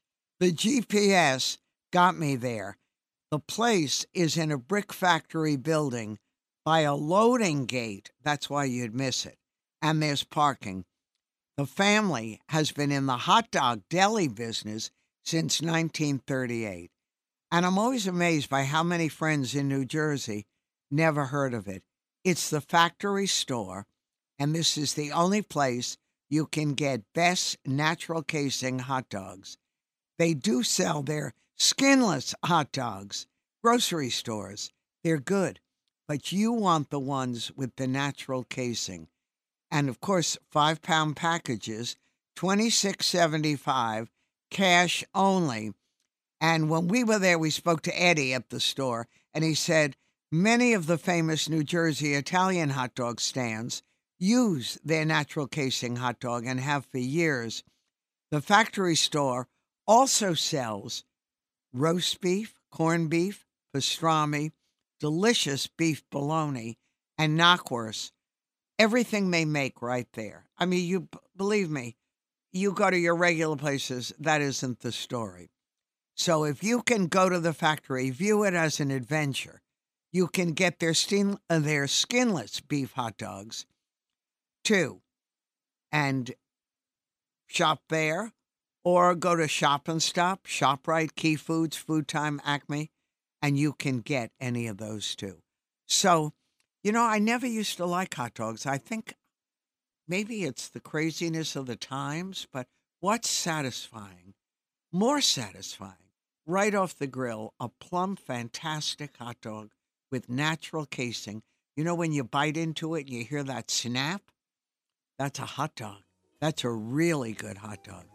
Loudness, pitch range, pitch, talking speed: -27 LUFS, 130-175 Hz, 150 Hz, 140 wpm